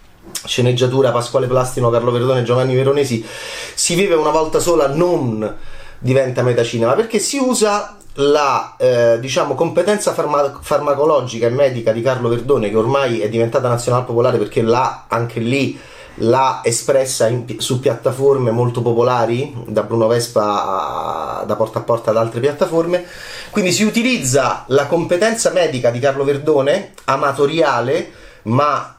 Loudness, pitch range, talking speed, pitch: -16 LUFS, 115-145 Hz, 140 wpm, 130 Hz